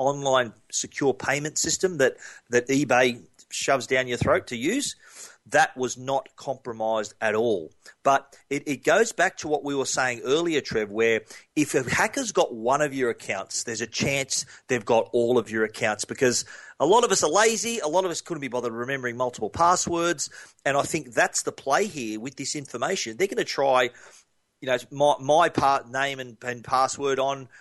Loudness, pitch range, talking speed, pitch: -25 LUFS, 125-150 Hz, 195 wpm, 135 Hz